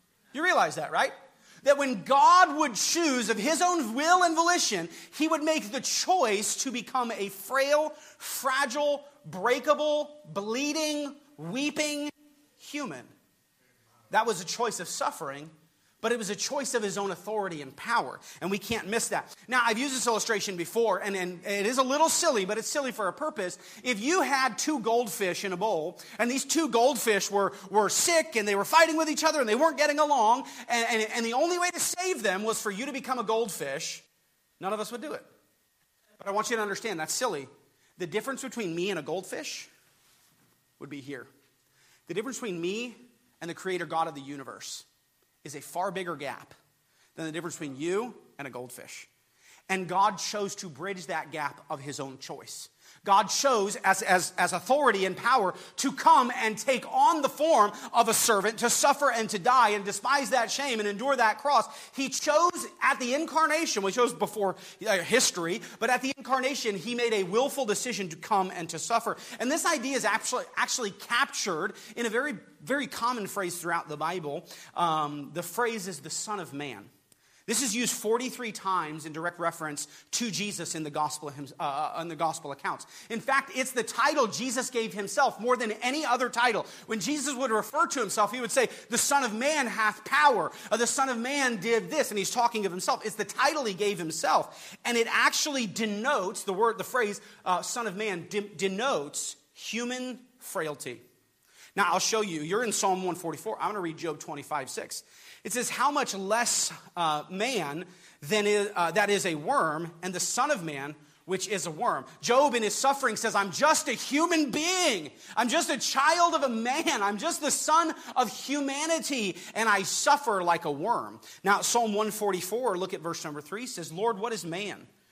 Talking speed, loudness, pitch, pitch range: 195 wpm, -28 LUFS, 225 Hz, 185-270 Hz